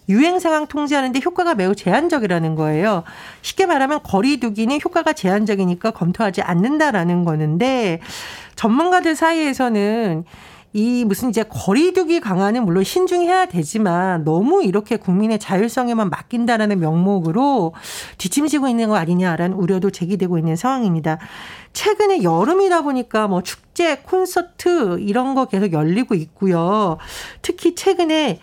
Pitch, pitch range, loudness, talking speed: 220 Hz, 185-300 Hz, -18 LUFS, 345 characters per minute